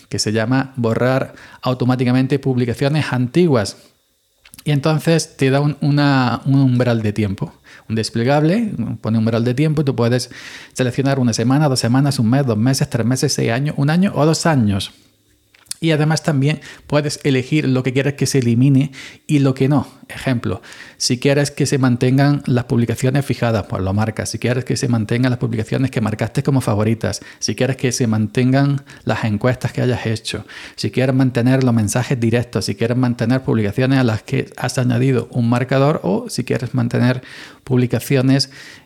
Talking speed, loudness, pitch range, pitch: 180 wpm, -17 LUFS, 120-140 Hz, 130 Hz